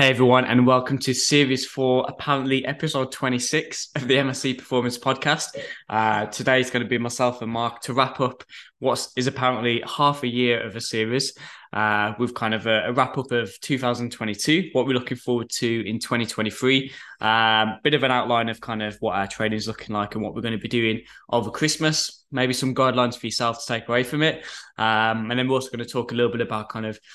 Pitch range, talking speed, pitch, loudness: 115-130 Hz, 225 wpm, 125 Hz, -23 LUFS